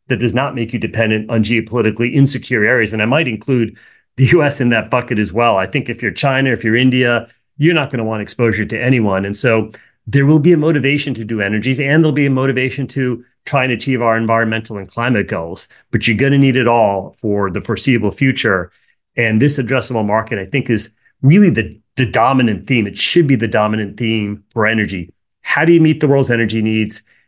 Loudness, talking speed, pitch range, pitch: -14 LUFS, 215 wpm, 110-135 Hz, 120 Hz